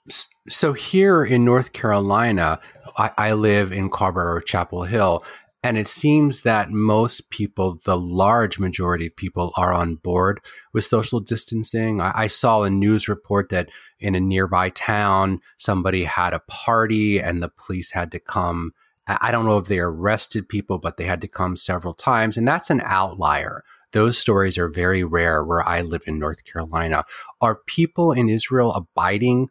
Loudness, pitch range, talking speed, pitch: -20 LUFS, 90-110 Hz, 170 wpm, 100 Hz